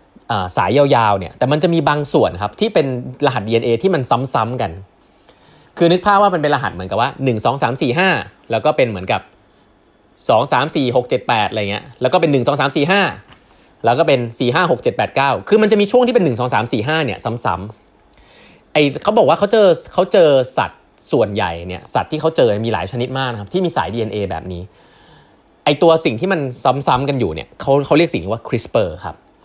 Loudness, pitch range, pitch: -16 LUFS, 115-165 Hz, 135 Hz